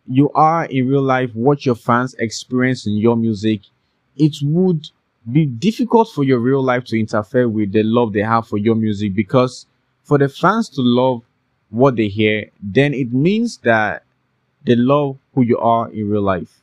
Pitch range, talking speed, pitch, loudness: 115-140 Hz, 185 wpm, 125 Hz, -17 LUFS